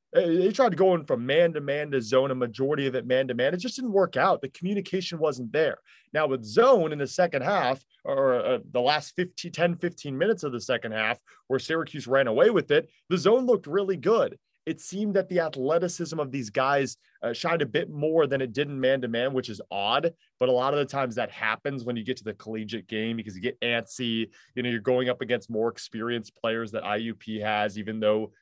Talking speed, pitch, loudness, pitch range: 240 wpm, 135 Hz, -26 LUFS, 115-170 Hz